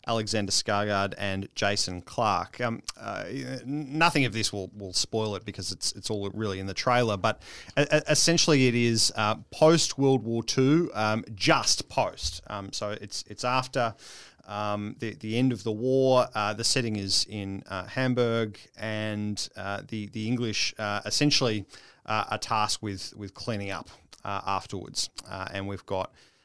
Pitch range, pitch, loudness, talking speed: 100-125 Hz, 110 Hz, -27 LUFS, 165 wpm